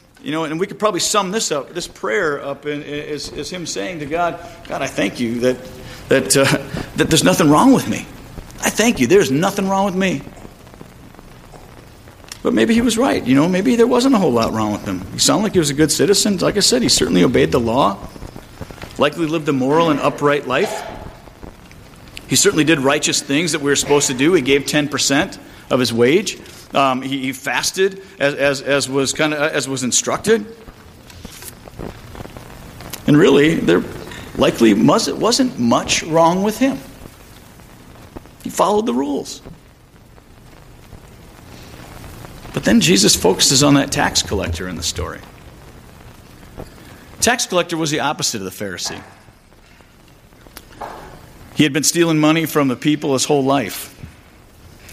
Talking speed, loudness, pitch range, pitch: 165 wpm, -16 LUFS, 135-185 Hz, 150 Hz